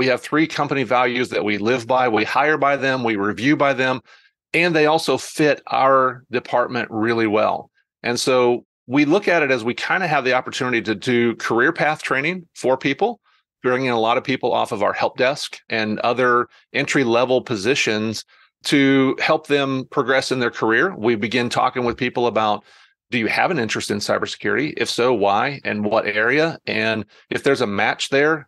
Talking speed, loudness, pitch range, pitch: 195 wpm, -19 LUFS, 115-140 Hz, 125 Hz